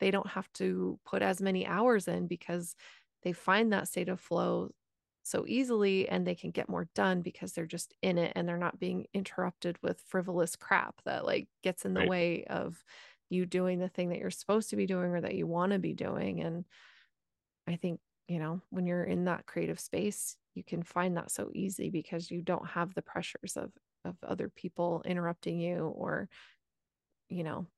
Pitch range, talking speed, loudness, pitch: 170-190 Hz, 200 wpm, -34 LUFS, 180 Hz